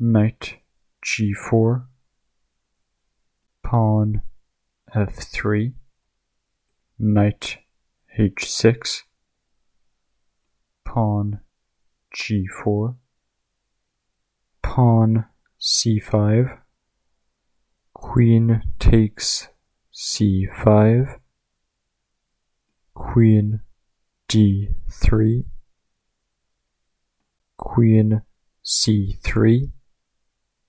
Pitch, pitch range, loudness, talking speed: 110 Hz, 100-115 Hz, -20 LUFS, 35 wpm